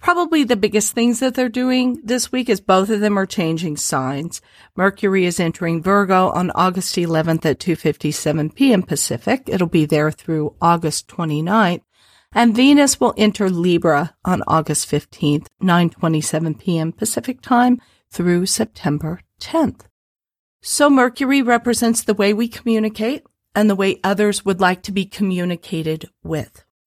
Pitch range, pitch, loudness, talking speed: 165-230 Hz, 190 Hz, -18 LUFS, 145 wpm